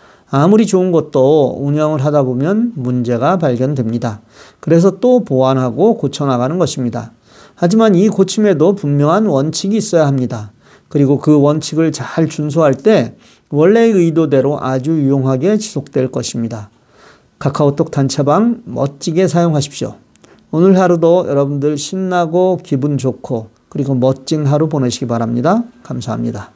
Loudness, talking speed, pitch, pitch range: -14 LUFS, 325 characters per minute, 145 Hz, 130-180 Hz